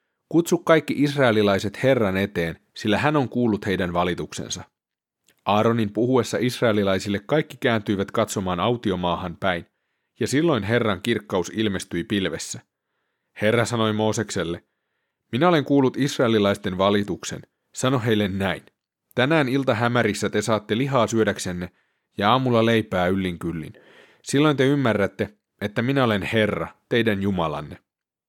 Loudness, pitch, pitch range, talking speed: -22 LUFS, 110 Hz, 95-125 Hz, 120 wpm